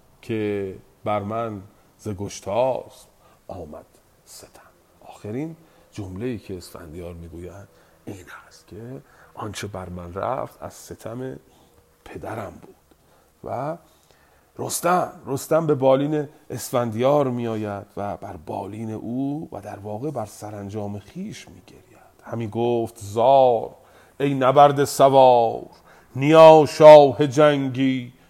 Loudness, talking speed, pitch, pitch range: -19 LUFS, 110 wpm, 115 Hz, 100-135 Hz